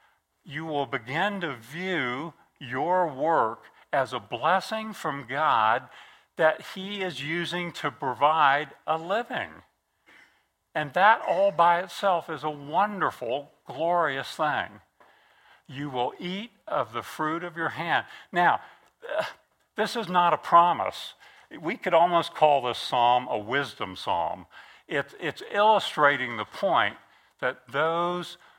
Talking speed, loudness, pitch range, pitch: 125 wpm, -26 LUFS, 140-180 Hz, 165 Hz